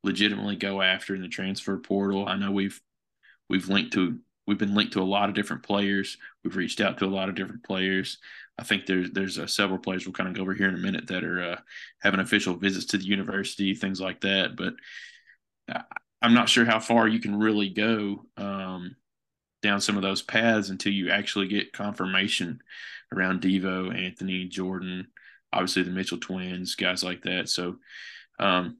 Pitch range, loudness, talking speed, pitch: 95-100 Hz, -27 LUFS, 195 wpm, 95 Hz